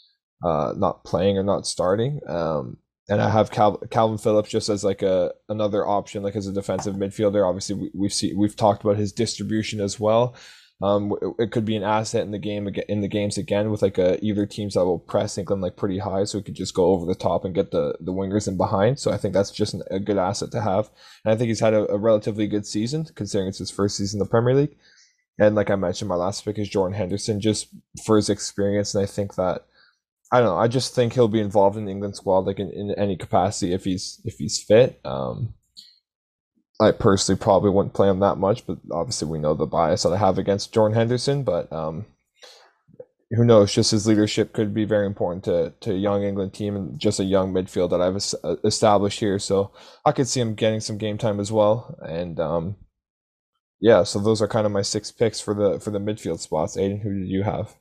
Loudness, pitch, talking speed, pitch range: -23 LUFS, 105 Hz, 235 wpm, 100-110 Hz